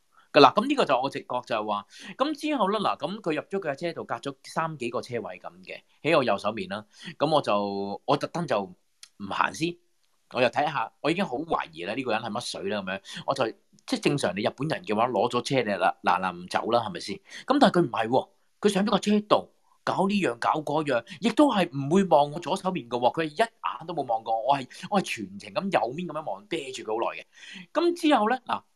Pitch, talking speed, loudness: 175 Hz, 330 characters per minute, -27 LUFS